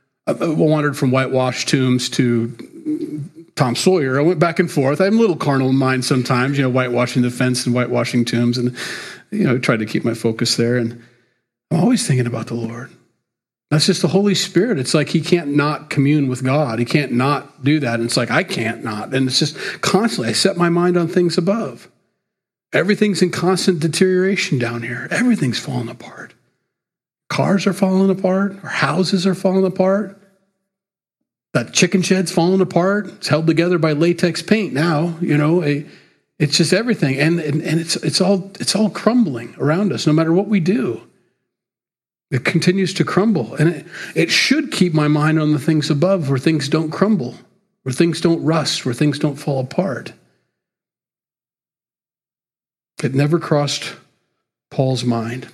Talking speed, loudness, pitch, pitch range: 175 wpm, -17 LUFS, 155 Hz, 130-190 Hz